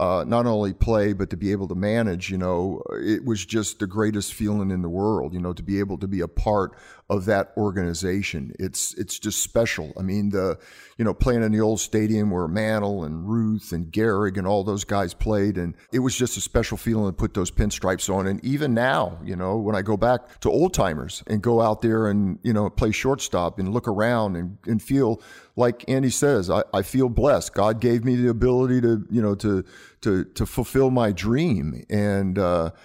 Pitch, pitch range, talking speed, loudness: 105 Hz, 95-115 Hz, 220 wpm, -23 LUFS